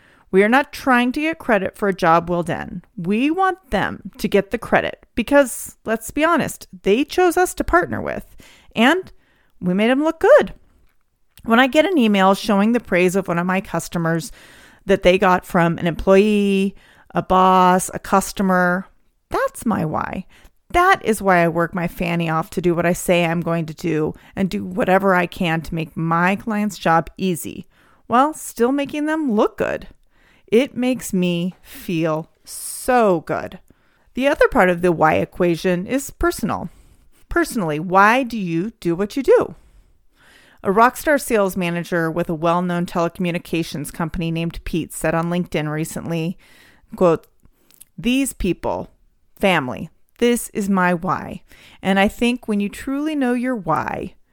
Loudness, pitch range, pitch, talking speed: -19 LUFS, 175-245 Hz, 195 Hz, 165 wpm